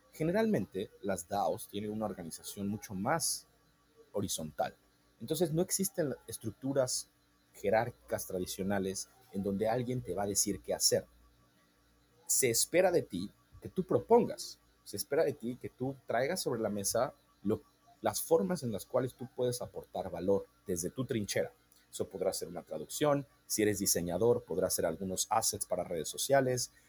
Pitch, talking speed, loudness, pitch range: 110 Hz, 155 wpm, -34 LUFS, 95-135 Hz